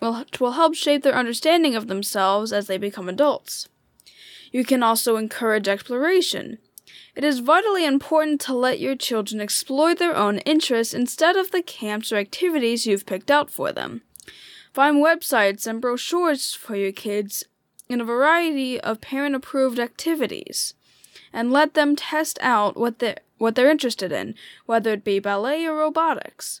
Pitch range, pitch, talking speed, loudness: 220-305 Hz, 255 Hz, 160 wpm, -21 LUFS